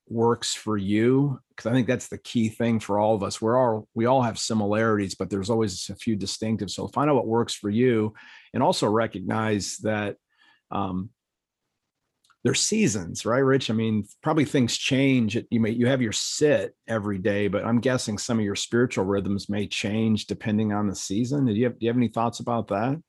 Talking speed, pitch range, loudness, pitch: 205 wpm, 105-120 Hz, -25 LUFS, 110 Hz